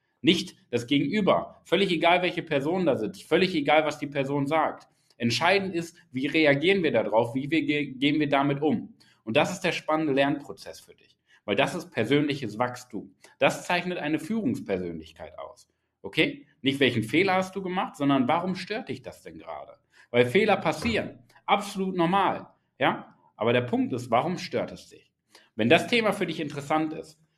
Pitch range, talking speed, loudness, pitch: 140-180 Hz, 175 wpm, -26 LUFS, 155 Hz